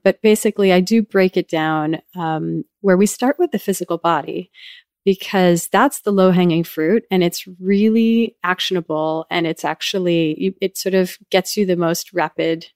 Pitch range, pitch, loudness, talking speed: 165-205 Hz, 185 Hz, -18 LUFS, 170 wpm